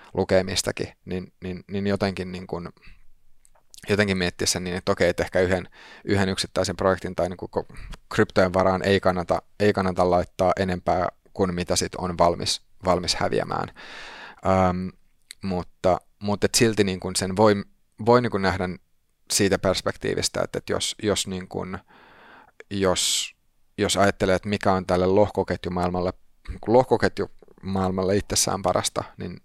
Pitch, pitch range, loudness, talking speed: 95 Hz, 90-100 Hz, -24 LUFS, 135 wpm